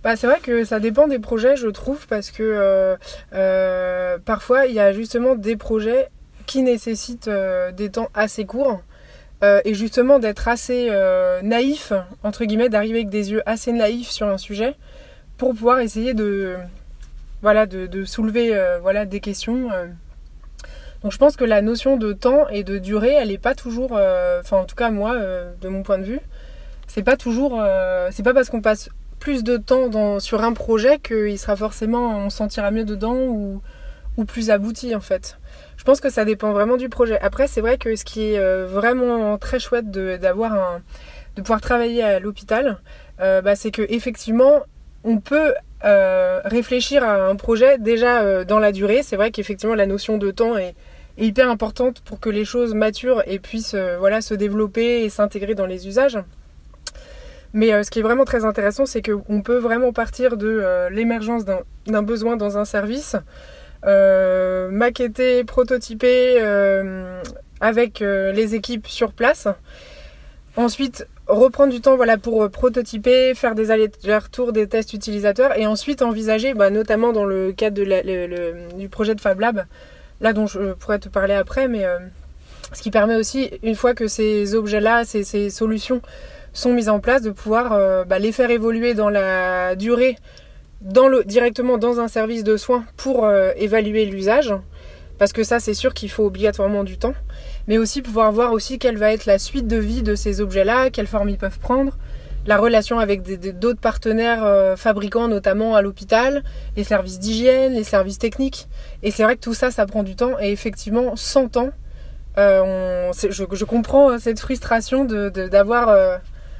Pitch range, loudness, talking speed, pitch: 200-245 Hz, -19 LUFS, 190 wpm, 220 Hz